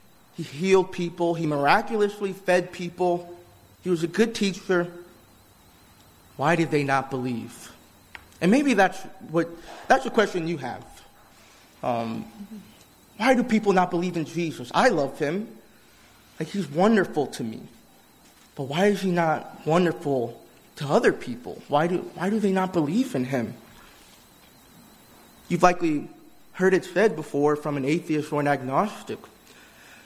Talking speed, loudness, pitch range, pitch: 145 wpm, -24 LUFS, 145-190 Hz, 170 Hz